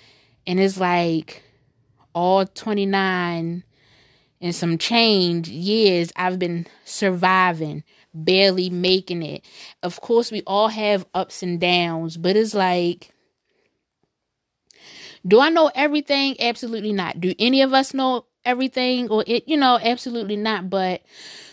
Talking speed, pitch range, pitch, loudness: 130 wpm, 175-225 Hz, 185 Hz, -20 LUFS